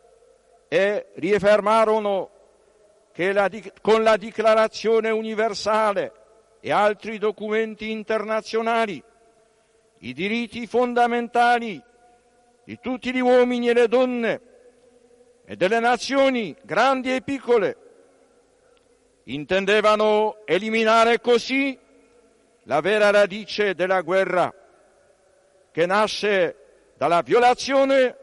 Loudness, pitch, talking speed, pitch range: -21 LUFS, 225 Hz, 85 wpm, 215-245 Hz